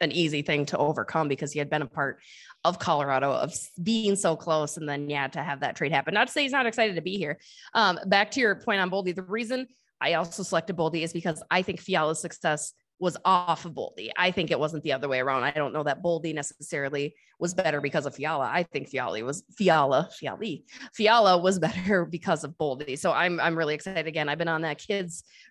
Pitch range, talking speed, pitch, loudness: 150-190 Hz, 235 wpm, 165 Hz, -27 LUFS